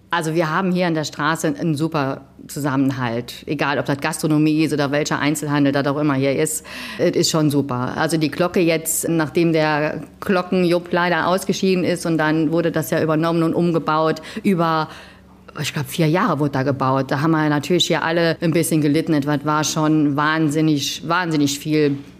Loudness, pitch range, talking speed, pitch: -19 LUFS, 145-165 Hz, 185 wpm, 155 Hz